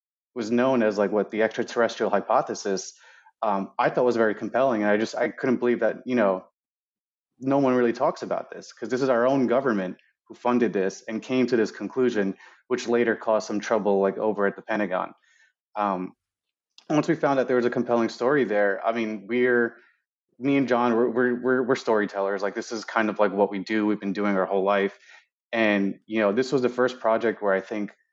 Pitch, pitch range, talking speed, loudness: 110 Hz, 100-120 Hz, 220 wpm, -24 LUFS